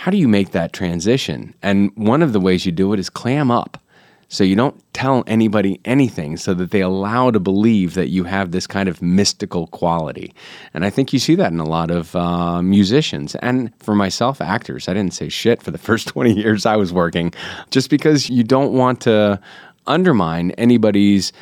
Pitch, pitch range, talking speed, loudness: 100 Hz, 90-120 Hz, 205 wpm, -17 LUFS